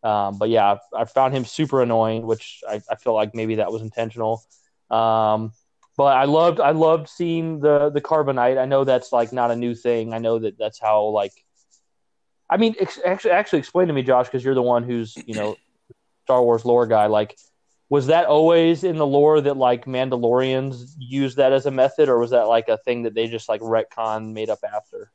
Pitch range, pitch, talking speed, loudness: 115-140 Hz, 120 Hz, 215 wpm, -20 LUFS